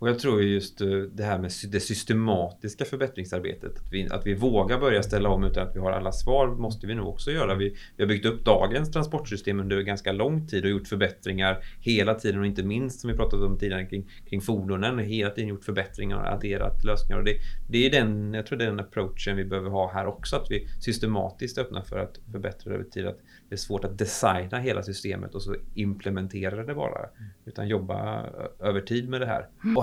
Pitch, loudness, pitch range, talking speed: 100 Hz, -28 LUFS, 95-115 Hz, 220 wpm